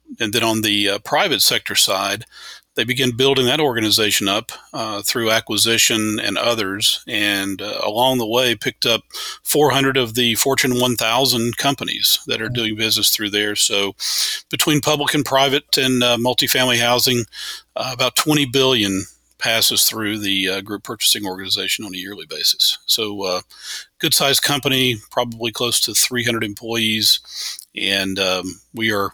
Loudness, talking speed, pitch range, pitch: -17 LUFS, 155 wpm, 105-130 Hz, 115 Hz